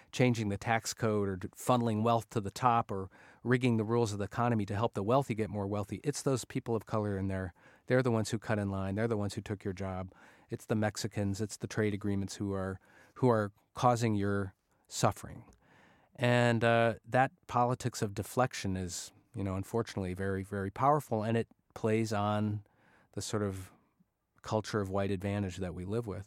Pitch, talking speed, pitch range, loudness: 105 Hz, 200 wpm, 100-115 Hz, -33 LUFS